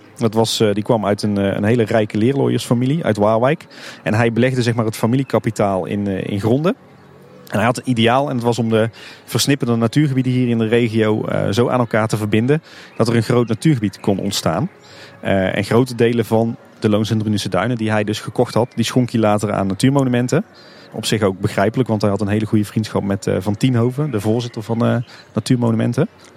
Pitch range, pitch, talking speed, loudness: 105-125 Hz, 115 Hz, 205 wpm, -18 LUFS